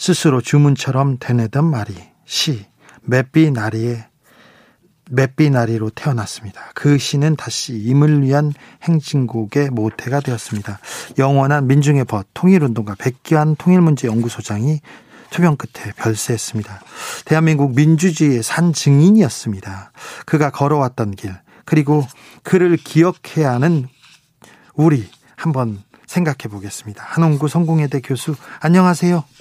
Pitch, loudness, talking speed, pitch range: 140 Hz, -16 LUFS, 295 characters per minute, 115-155 Hz